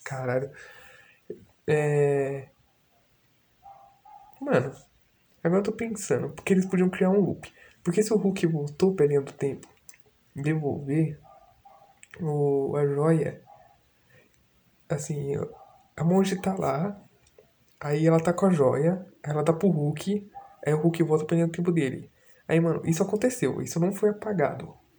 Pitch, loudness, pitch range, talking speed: 170 Hz, -26 LUFS, 150-200 Hz, 130 wpm